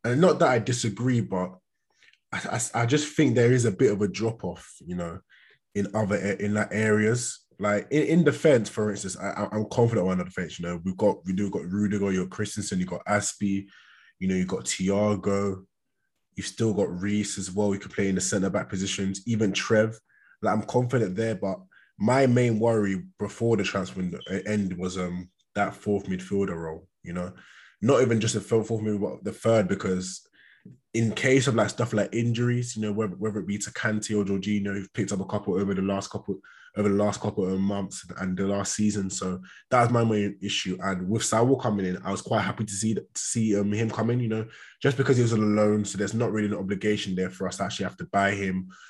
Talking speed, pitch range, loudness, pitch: 235 wpm, 95-110 Hz, -26 LUFS, 105 Hz